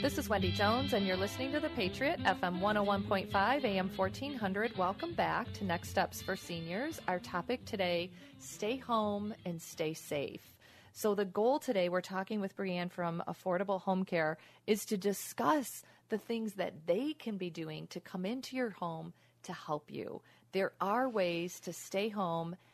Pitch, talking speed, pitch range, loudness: 190 Hz, 170 wpm, 175-215 Hz, -36 LUFS